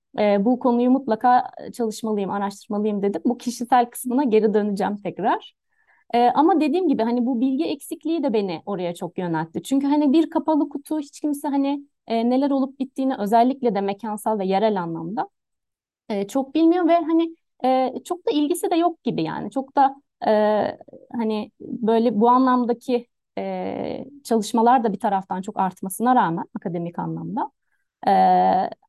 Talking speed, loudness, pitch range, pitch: 155 wpm, -22 LUFS, 210-285 Hz, 245 Hz